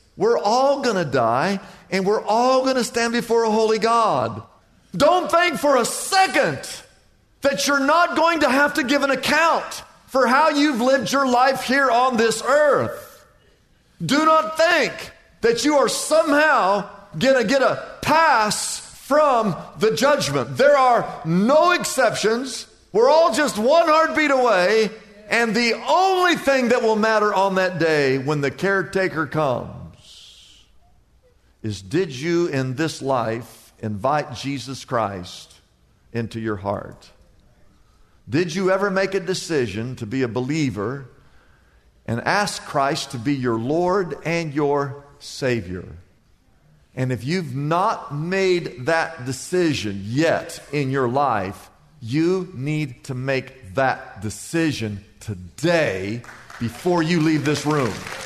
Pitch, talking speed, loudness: 180 Hz, 135 wpm, -20 LUFS